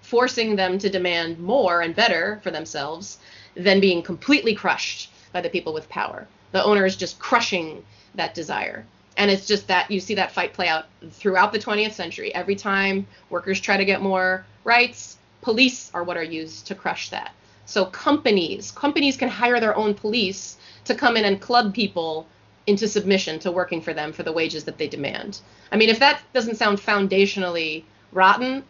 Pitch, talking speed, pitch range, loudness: 195 Hz, 185 wpm, 175-220 Hz, -21 LUFS